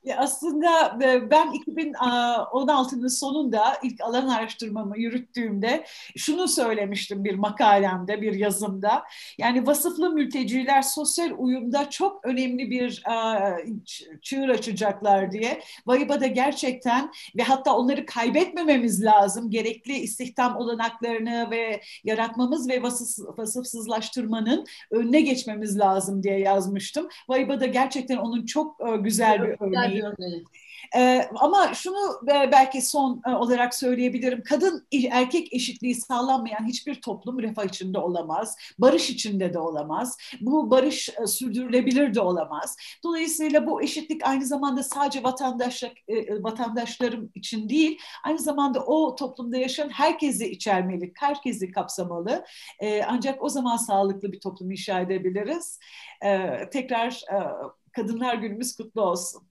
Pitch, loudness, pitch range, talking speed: 245 Hz, -25 LUFS, 215-275 Hz, 115 wpm